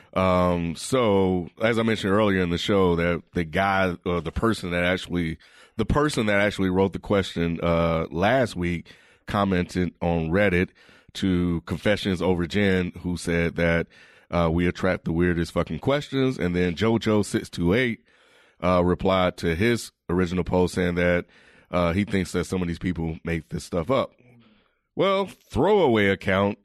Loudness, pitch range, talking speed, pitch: -24 LUFS, 85-100 Hz, 165 wpm, 90 Hz